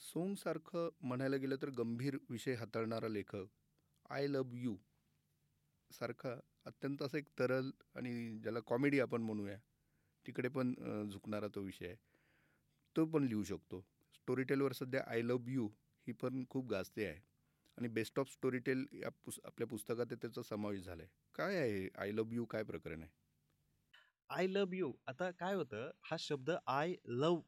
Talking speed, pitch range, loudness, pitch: 155 wpm, 110-140 Hz, -42 LUFS, 125 Hz